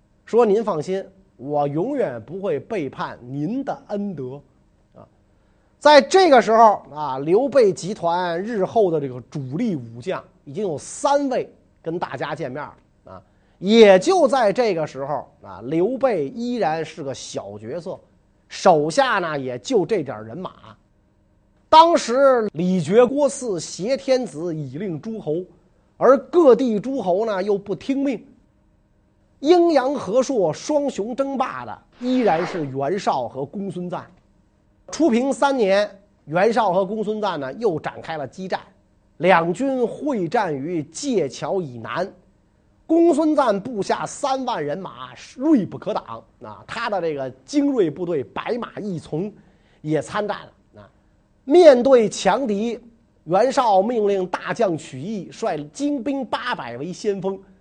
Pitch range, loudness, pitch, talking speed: 150-255 Hz, -20 LUFS, 195 Hz, 200 characters per minute